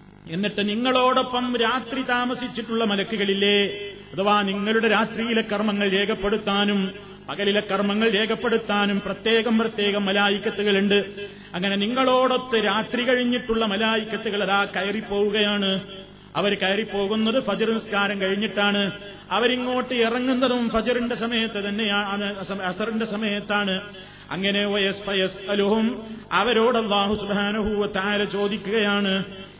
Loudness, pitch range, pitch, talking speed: -22 LUFS, 200-225 Hz, 205 Hz, 85 wpm